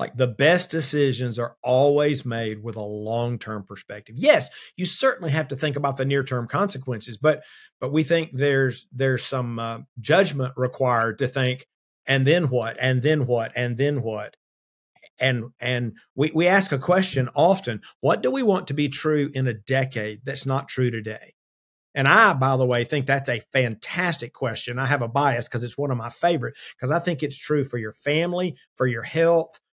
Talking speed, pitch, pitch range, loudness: 195 wpm, 130 Hz, 120-150 Hz, -23 LUFS